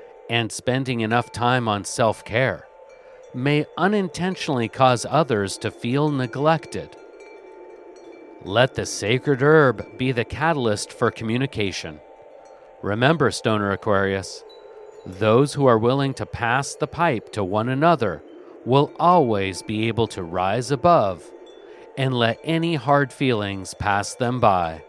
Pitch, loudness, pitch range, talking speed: 130 Hz, -21 LUFS, 115-170 Hz, 125 wpm